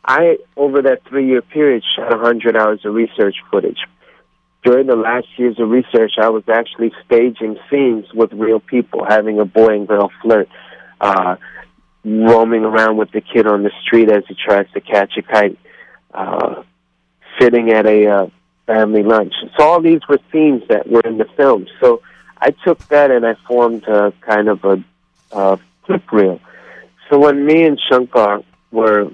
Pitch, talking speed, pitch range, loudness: 110 Hz, 175 wpm, 105-125 Hz, -13 LUFS